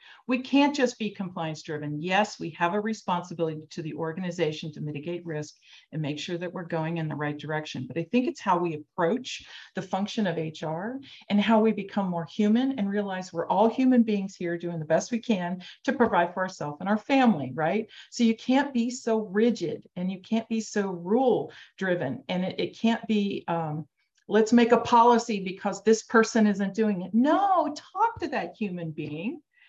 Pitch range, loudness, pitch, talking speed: 170-230 Hz, -27 LUFS, 200 Hz, 200 wpm